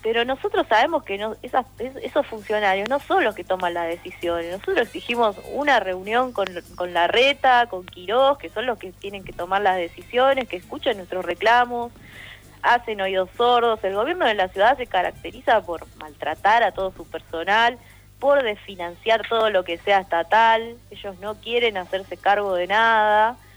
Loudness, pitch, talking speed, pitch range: -21 LUFS, 210 Hz, 175 wpm, 185-240 Hz